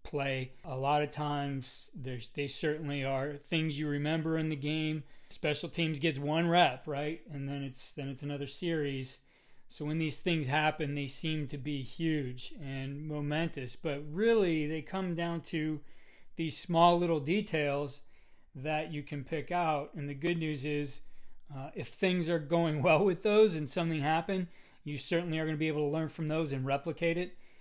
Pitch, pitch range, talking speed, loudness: 155 Hz, 145-165 Hz, 185 wpm, -33 LUFS